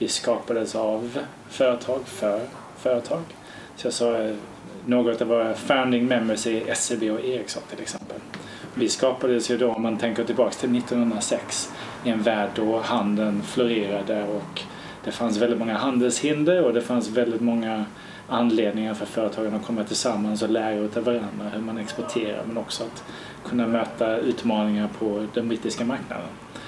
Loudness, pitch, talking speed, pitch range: -25 LUFS, 115 Hz, 150 wpm, 110-120 Hz